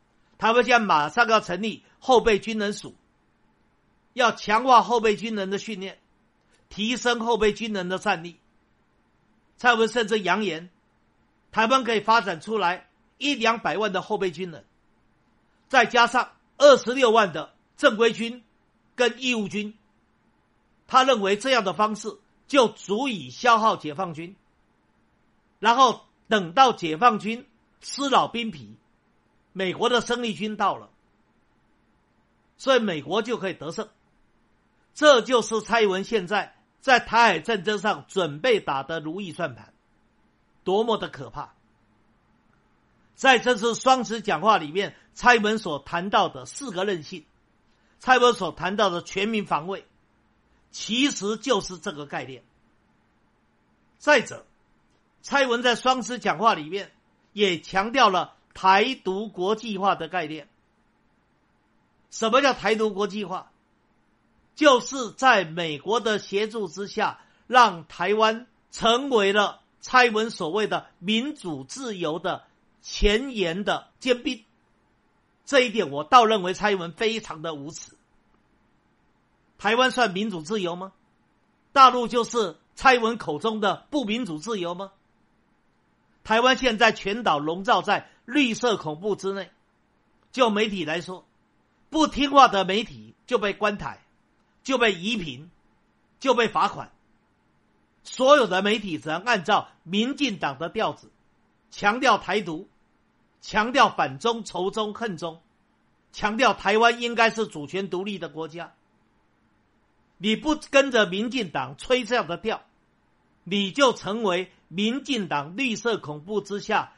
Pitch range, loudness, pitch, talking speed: 185-235 Hz, -23 LUFS, 210 Hz, 195 characters per minute